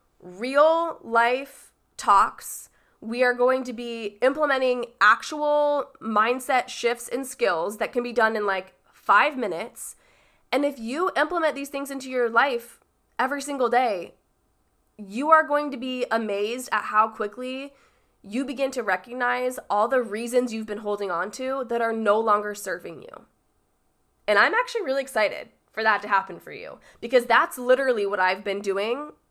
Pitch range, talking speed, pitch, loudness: 215-275 Hz, 160 wpm, 245 Hz, -24 LUFS